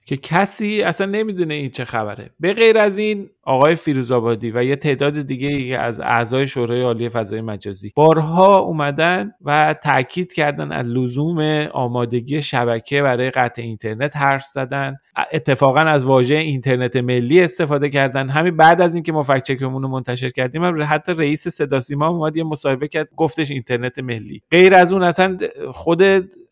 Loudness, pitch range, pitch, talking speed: -17 LUFS, 130-165 Hz, 145 Hz, 160 wpm